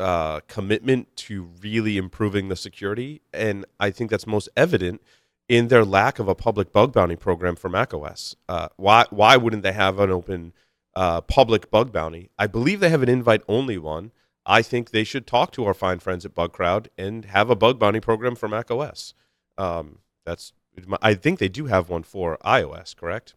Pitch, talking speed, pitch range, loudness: 100 Hz, 190 wpm, 95-115 Hz, -21 LUFS